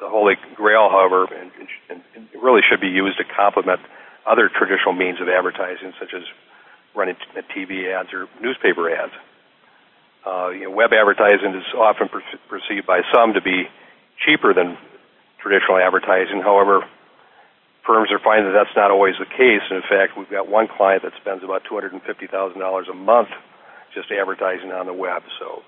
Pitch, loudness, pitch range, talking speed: 95 Hz, -17 LUFS, 95-100 Hz, 180 wpm